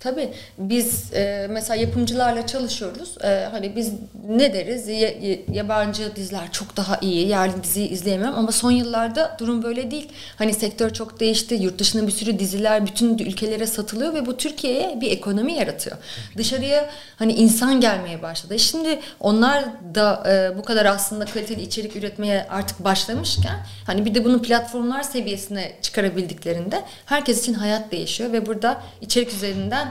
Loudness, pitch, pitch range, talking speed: -22 LUFS, 220 Hz, 200-240 Hz, 145 wpm